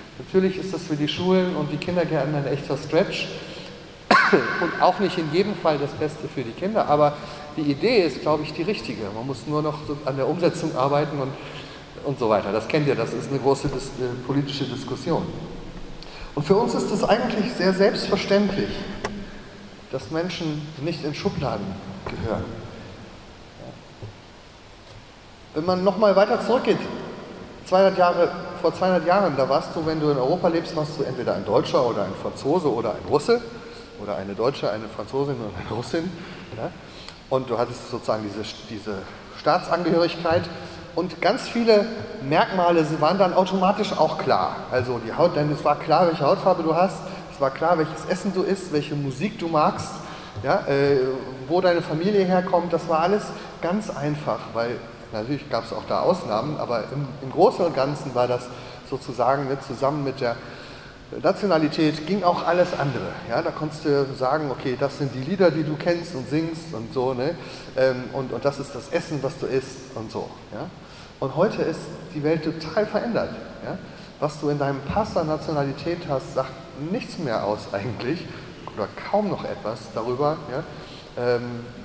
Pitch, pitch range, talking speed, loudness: 150 Hz, 130-175 Hz, 175 wpm, -24 LUFS